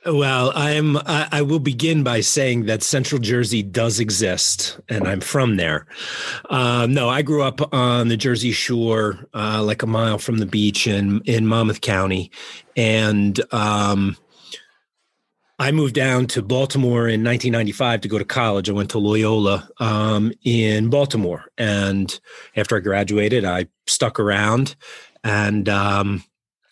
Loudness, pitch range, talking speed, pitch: -19 LUFS, 105-125 Hz, 150 wpm, 115 Hz